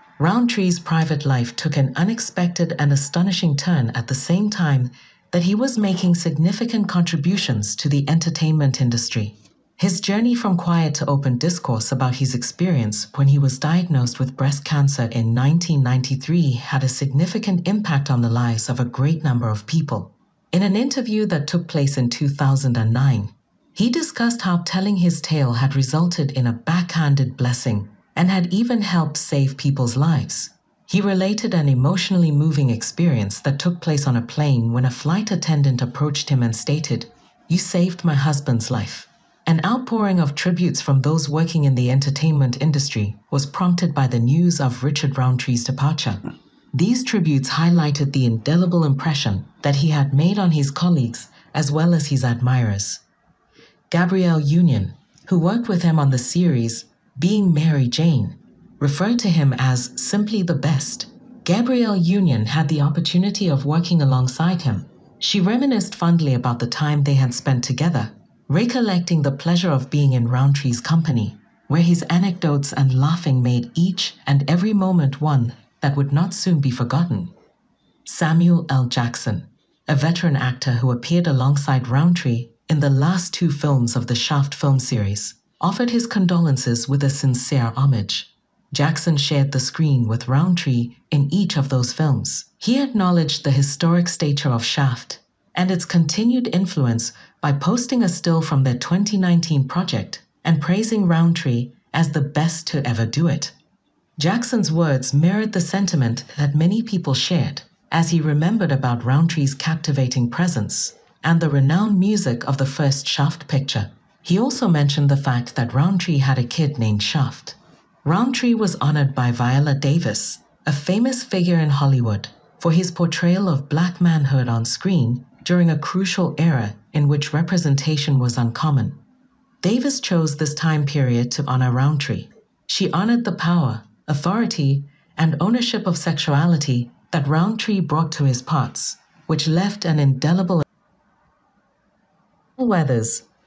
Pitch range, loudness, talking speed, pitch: 130-175 Hz, -19 LUFS, 155 wpm, 150 Hz